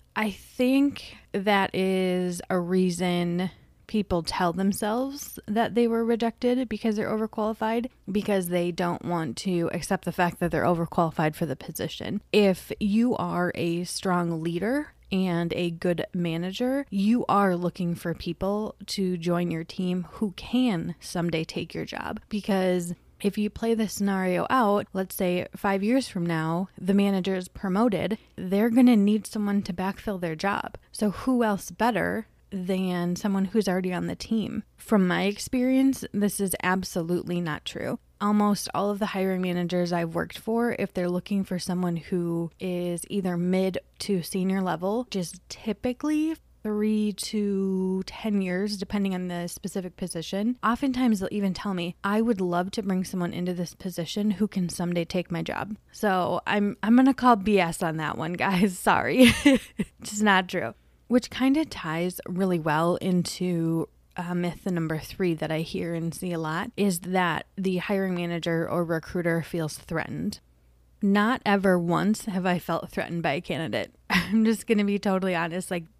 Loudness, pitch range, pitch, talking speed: -26 LUFS, 175-210 Hz, 190 Hz, 165 wpm